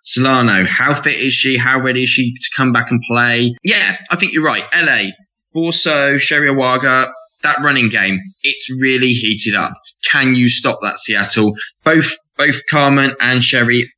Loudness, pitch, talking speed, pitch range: -13 LUFS, 130 Hz, 170 wpm, 120-140 Hz